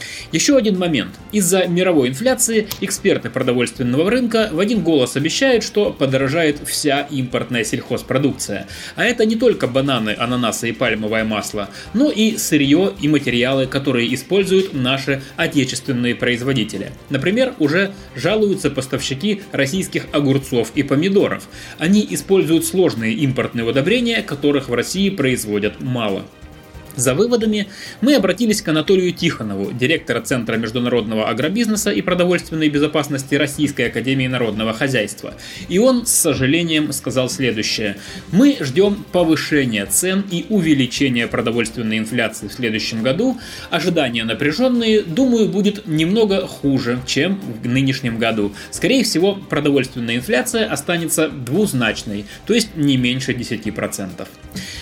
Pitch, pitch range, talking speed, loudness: 145 Hz, 120-190 Hz, 120 wpm, -18 LUFS